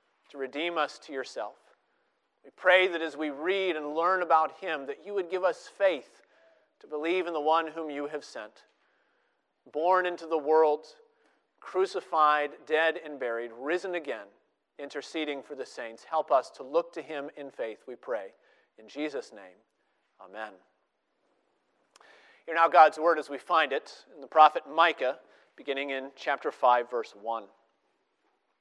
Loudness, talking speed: -28 LUFS, 160 wpm